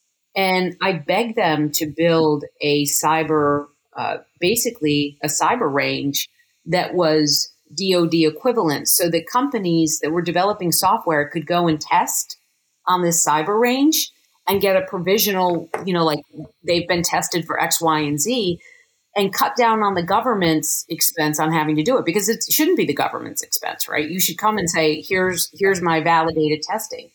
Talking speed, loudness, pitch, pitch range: 170 wpm, -19 LUFS, 170 Hz, 155-200 Hz